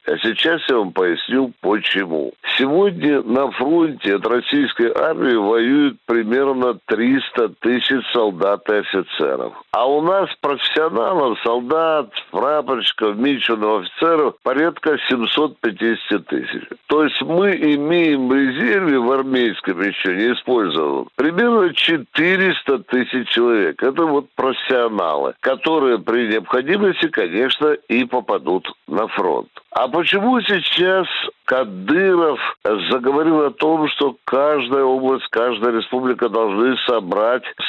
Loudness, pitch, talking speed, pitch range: -18 LUFS, 135 Hz, 110 wpm, 120-175 Hz